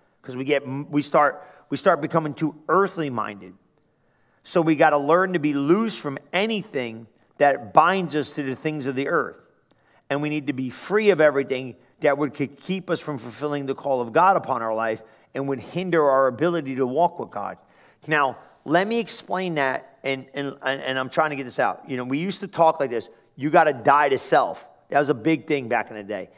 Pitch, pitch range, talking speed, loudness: 145 Hz, 135-165 Hz, 220 wpm, -23 LUFS